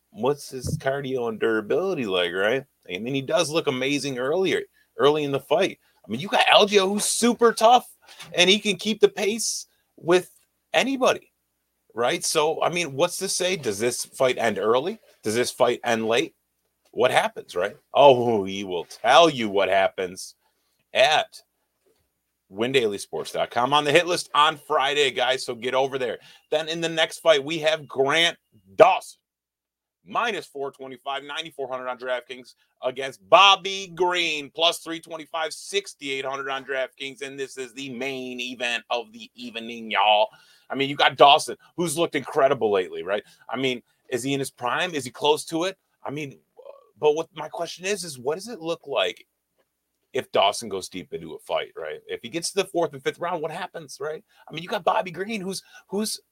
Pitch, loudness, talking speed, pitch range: 160 Hz, -23 LUFS, 180 wpm, 130-195 Hz